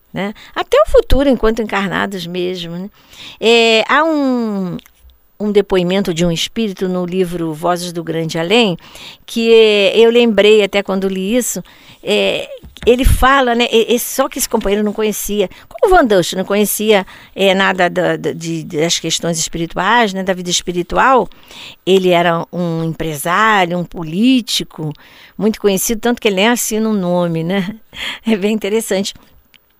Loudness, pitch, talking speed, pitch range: -14 LUFS, 195 Hz, 165 wpm, 175-225 Hz